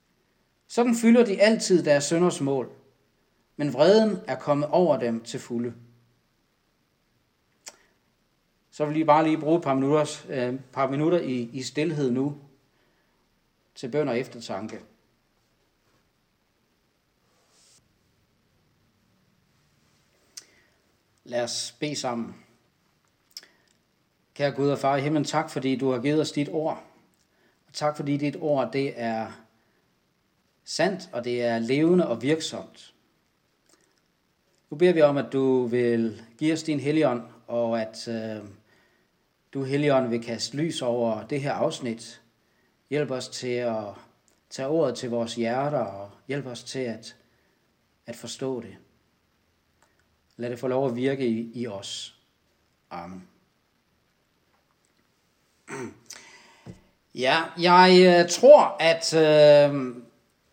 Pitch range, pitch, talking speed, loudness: 120-150 Hz, 135 Hz, 120 wpm, -24 LUFS